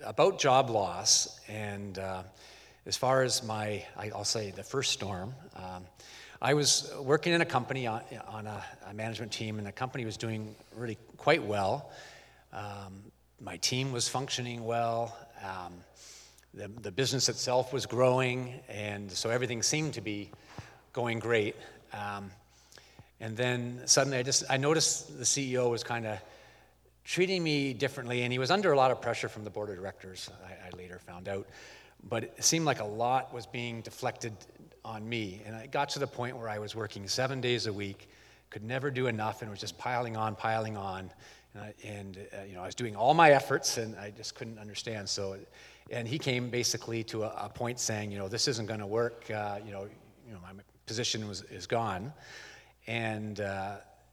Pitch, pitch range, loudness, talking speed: 115 Hz, 100-125 Hz, -31 LUFS, 190 wpm